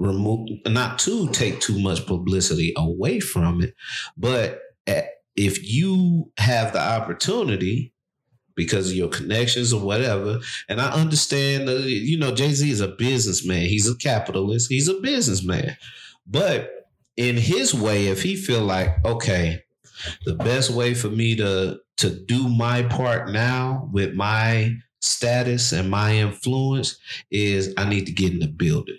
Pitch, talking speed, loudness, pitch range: 115 Hz, 150 wpm, -22 LUFS, 100-130 Hz